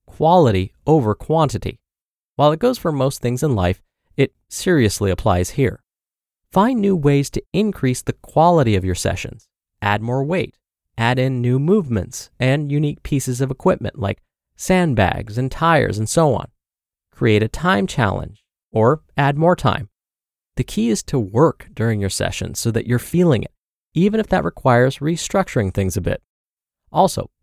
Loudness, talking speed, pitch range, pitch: -19 LUFS, 160 wpm, 110-160 Hz, 130 Hz